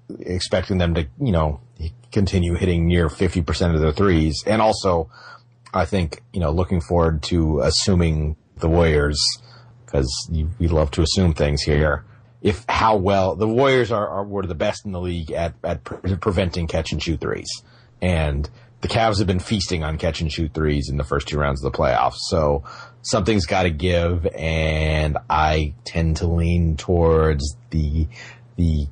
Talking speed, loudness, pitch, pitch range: 175 wpm, -21 LUFS, 85 Hz, 80-100 Hz